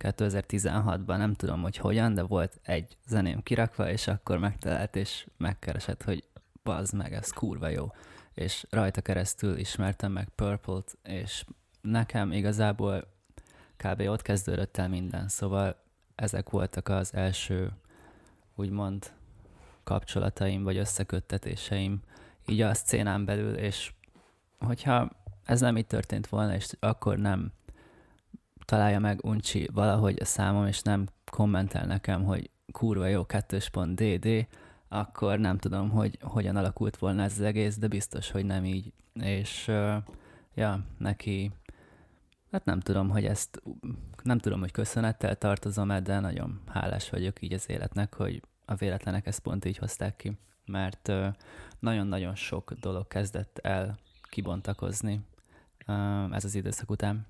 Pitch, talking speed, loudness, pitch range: 100 Hz, 140 wpm, -31 LUFS, 95-105 Hz